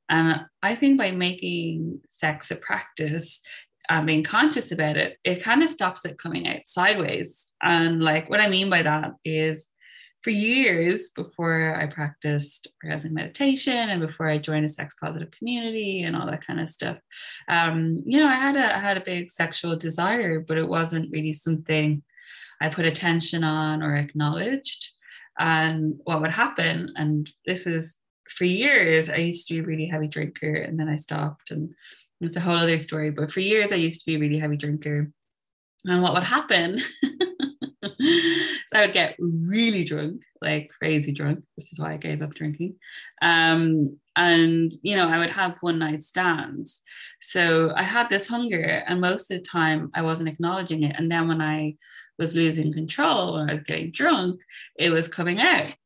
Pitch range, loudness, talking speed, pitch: 155-185 Hz, -24 LUFS, 185 wpm, 165 Hz